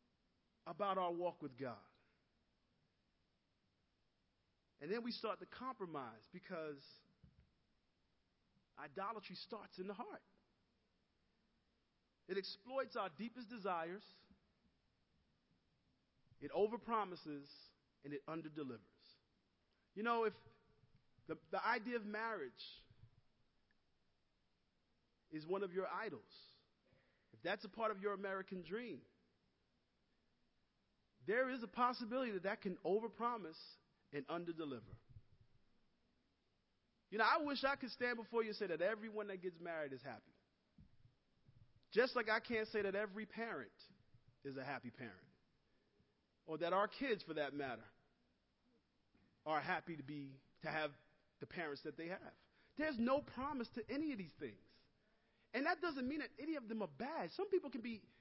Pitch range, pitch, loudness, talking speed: 140-225 Hz, 185 Hz, -44 LUFS, 135 wpm